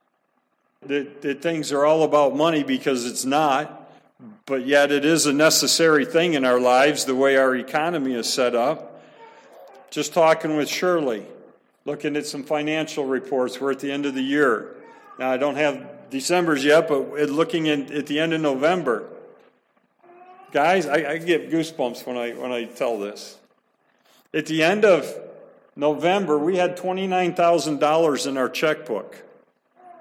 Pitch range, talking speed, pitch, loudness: 140-170 Hz, 160 wpm, 150 Hz, -21 LUFS